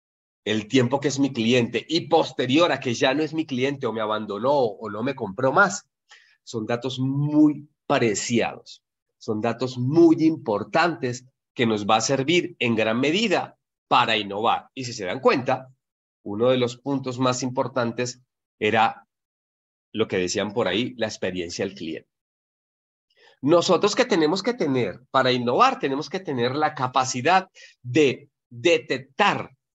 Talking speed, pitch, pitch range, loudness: 155 wpm, 130 Hz, 120-150 Hz, -23 LUFS